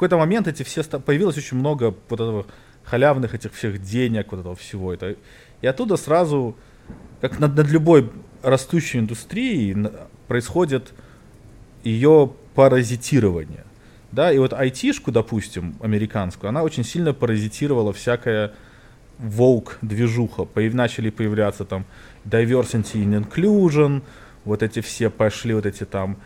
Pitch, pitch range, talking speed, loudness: 120 Hz, 105-135 Hz, 130 wpm, -21 LUFS